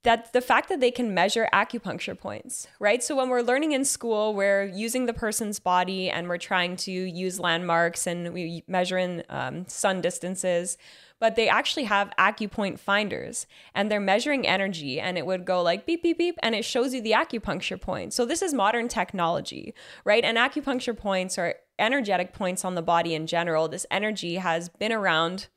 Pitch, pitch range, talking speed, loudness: 195 Hz, 180-230 Hz, 190 wpm, -26 LUFS